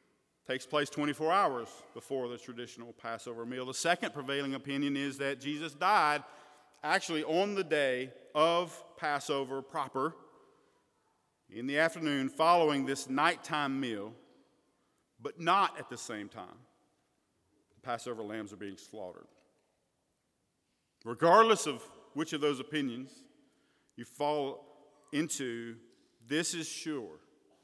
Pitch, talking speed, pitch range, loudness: 145 Hz, 120 wpm, 125-155 Hz, -32 LUFS